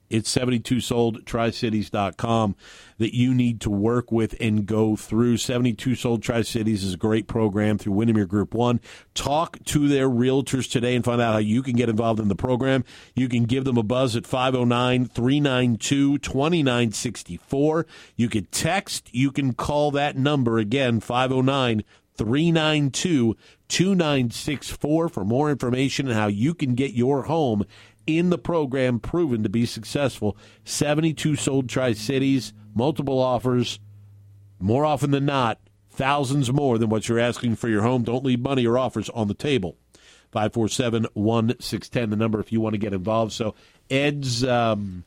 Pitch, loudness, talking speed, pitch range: 120 Hz, -23 LUFS, 150 wpm, 110-135 Hz